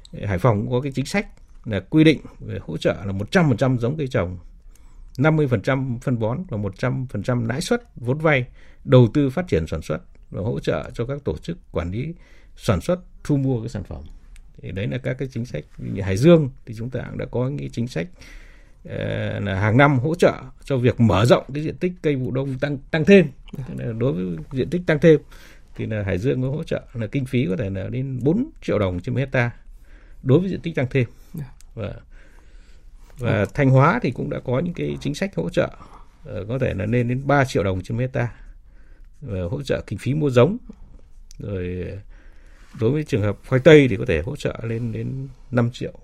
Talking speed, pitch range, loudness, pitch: 210 wpm, 100-140 Hz, -21 LUFS, 125 Hz